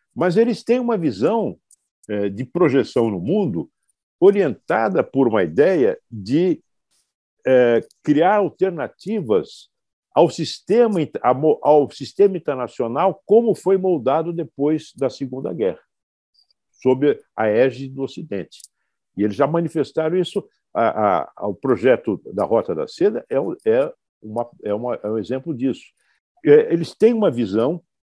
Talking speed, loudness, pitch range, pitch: 125 wpm, -20 LUFS, 130-210 Hz, 160 Hz